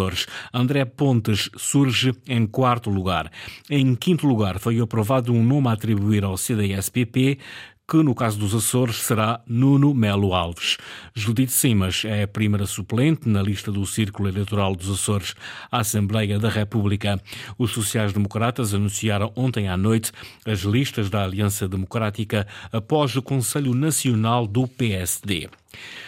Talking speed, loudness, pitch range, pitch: 140 wpm, -22 LUFS, 100-125 Hz, 110 Hz